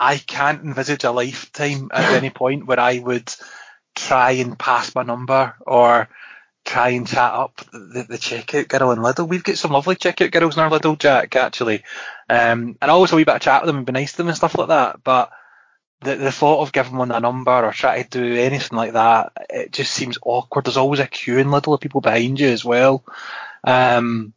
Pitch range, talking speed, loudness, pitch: 120-145 Hz, 220 wpm, -18 LUFS, 130 Hz